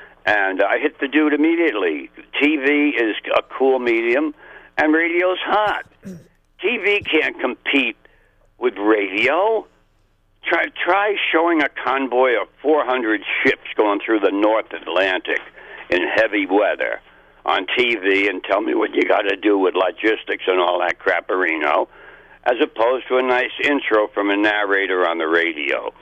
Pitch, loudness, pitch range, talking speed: 140 Hz, -18 LUFS, 110-175 Hz, 145 wpm